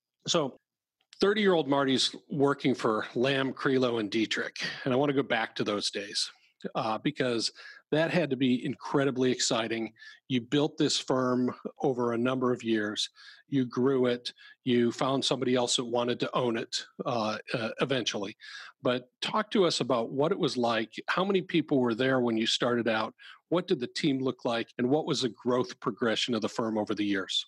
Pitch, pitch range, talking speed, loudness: 125 Hz, 120-140 Hz, 190 wpm, -29 LUFS